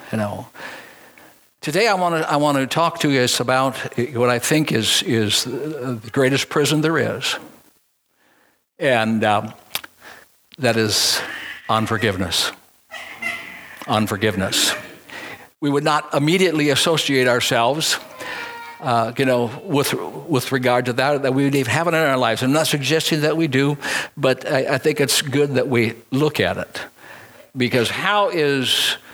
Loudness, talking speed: -19 LUFS, 150 wpm